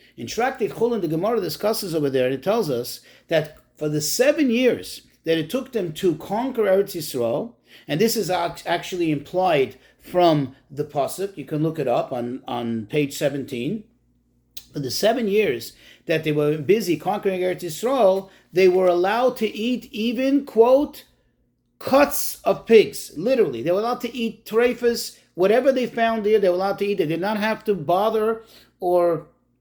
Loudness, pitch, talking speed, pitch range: -22 LUFS, 190 Hz, 175 wpm, 160-225 Hz